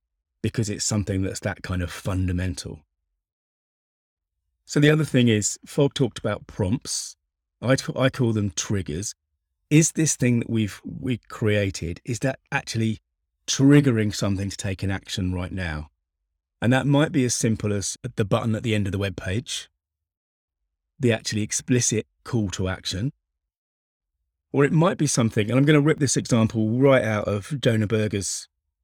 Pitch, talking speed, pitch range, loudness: 105 Hz, 165 wpm, 80-125 Hz, -23 LUFS